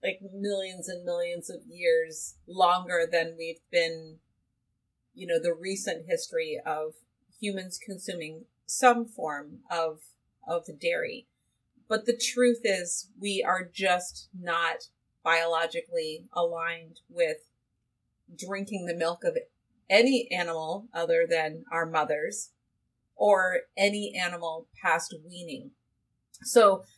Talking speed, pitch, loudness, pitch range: 110 wpm, 180 Hz, -29 LUFS, 165-230 Hz